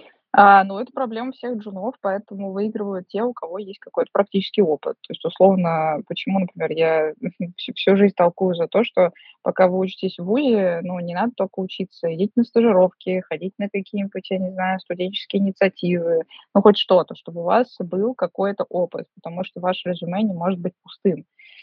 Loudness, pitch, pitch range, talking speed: -21 LUFS, 190 Hz, 180-205 Hz, 185 wpm